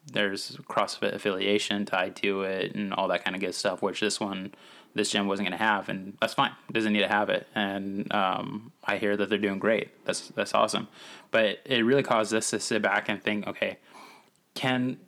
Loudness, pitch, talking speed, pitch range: -28 LUFS, 105 Hz, 210 wpm, 100-110 Hz